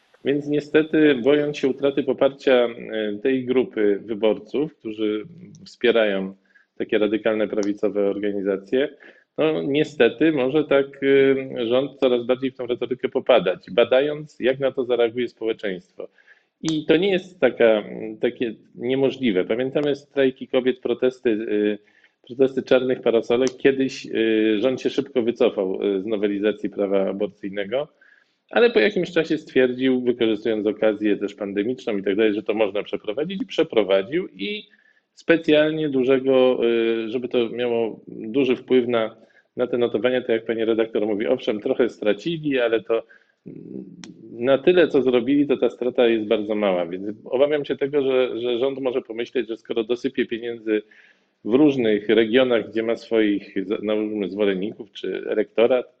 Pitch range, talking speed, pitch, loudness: 110-135 Hz, 135 wpm, 125 Hz, -22 LUFS